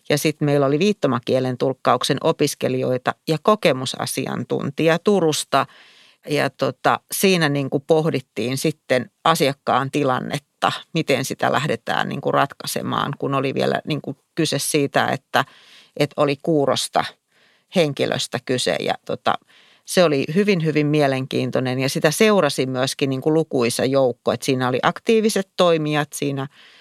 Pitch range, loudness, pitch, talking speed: 135-160 Hz, -20 LUFS, 145 Hz, 125 wpm